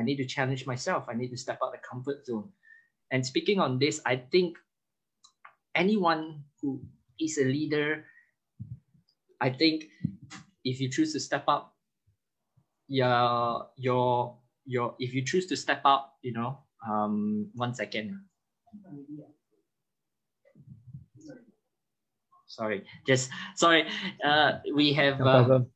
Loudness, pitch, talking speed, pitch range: -28 LUFS, 140 Hz, 125 wpm, 125-160 Hz